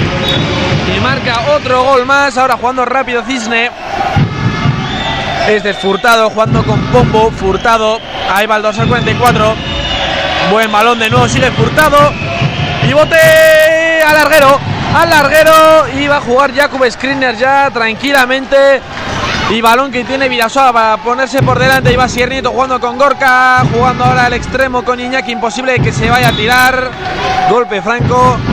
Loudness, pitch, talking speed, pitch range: -9 LUFS, 250 Hz, 150 wpm, 220-275 Hz